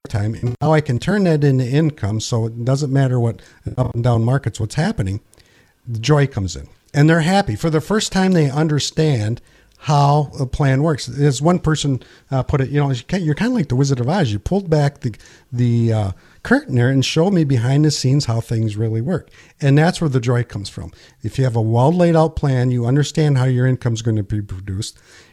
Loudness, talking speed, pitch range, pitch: -18 LUFS, 225 wpm, 115-155 Hz, 130 Hz